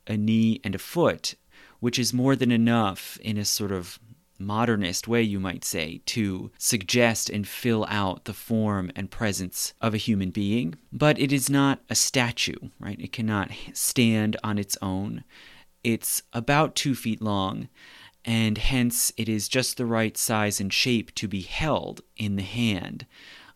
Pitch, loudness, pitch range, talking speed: 110 Hz, -25 LUFS, 100-120 Hz, 170 wpm